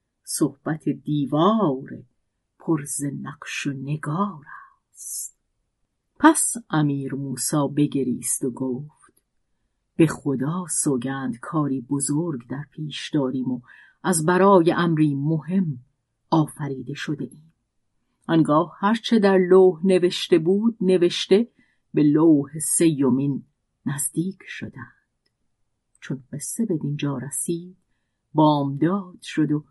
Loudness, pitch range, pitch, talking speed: -22 LUFS, 135-175 Hz, 150 Hz, 100 wpm